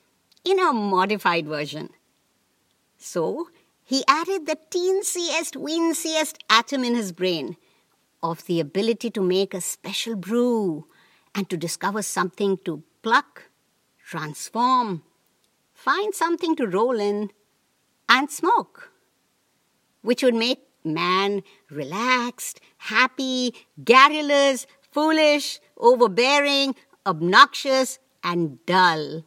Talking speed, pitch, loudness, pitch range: 100 wpm, 245 Hz, -22 LUFS, 190-300 Hz